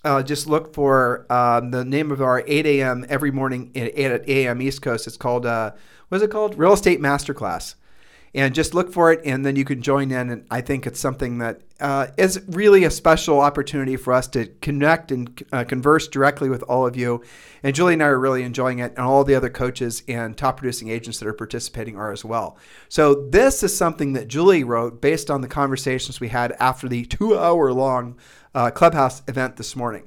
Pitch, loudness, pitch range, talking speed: 135 Hz, -20 LUFS, 125-145 Hz, 215 wpm